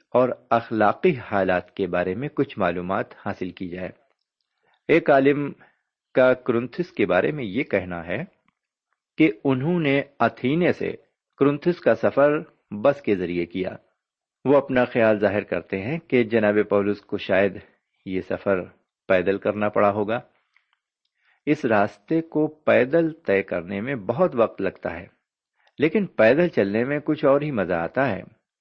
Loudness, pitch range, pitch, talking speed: -23 LUFS, 100-145 Hz, 115 Hz, 150 wpm